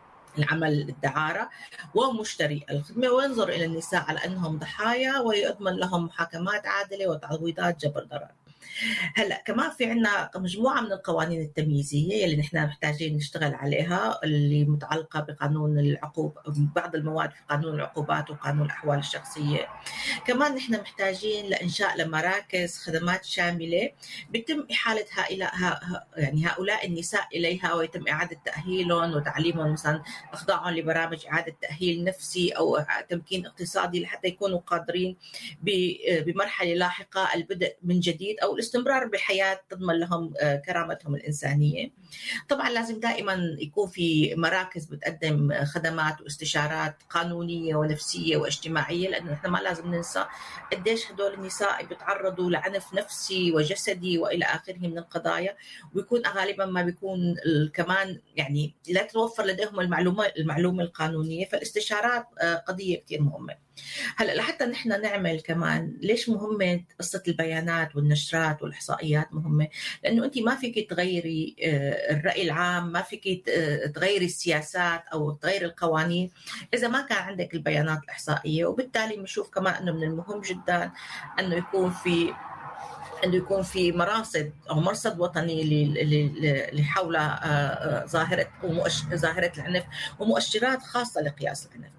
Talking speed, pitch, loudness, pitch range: 125 wpm, 175 Hz, -27 LUFS, 155-195 Hz